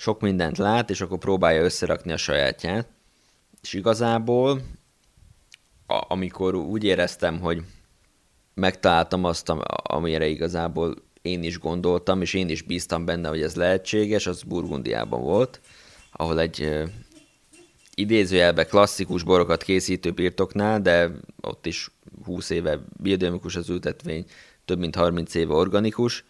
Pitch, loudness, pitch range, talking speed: 90 Hz, -24 LUFS, 85-100 Hz, 120 wpm